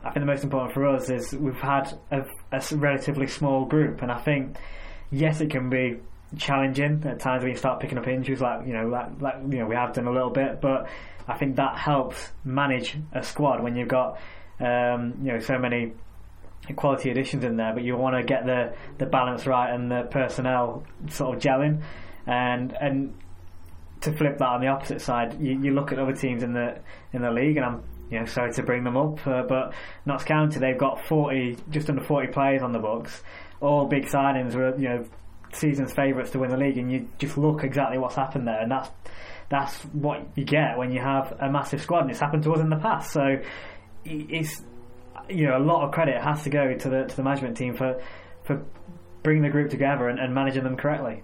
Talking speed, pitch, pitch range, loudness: 220 wpm, 130 Hz, 125-140 Hz, -26 LUFS